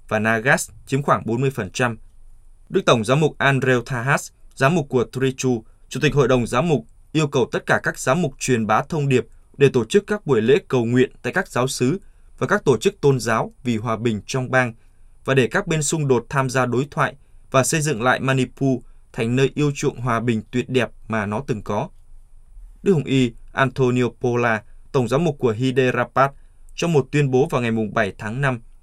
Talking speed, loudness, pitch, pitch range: 210 wpm, -20 LUFS, 130 Hz, 115-140 Hz